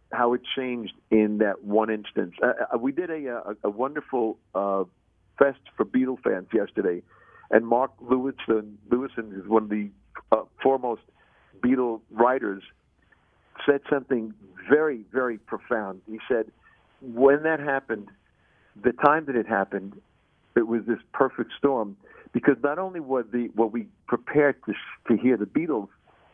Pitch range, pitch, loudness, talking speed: 105-135 Hz, 120 Hz, -26 LUFS, 150 wpm